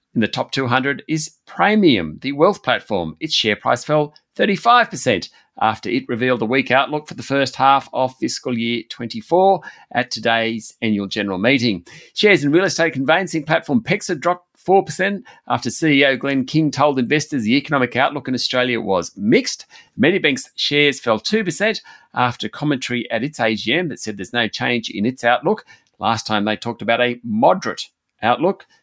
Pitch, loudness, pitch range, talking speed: 135 Hz, -18 LUFS, 120-165 Hz, 165 wpm